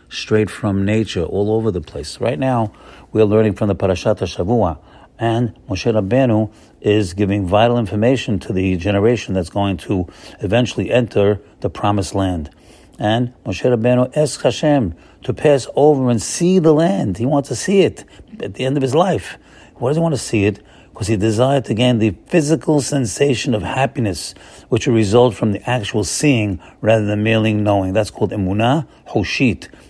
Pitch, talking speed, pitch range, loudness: 110 Hz, 175 wpm, 100-125 Hz, -17 LUFS